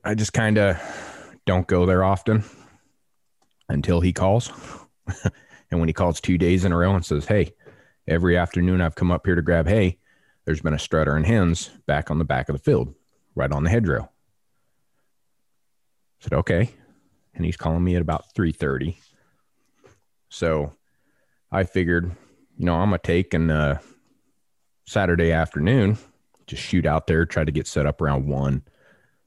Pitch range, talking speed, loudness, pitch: 80-95 Hz, 165 wpm, -22 LUFS, 85 Hz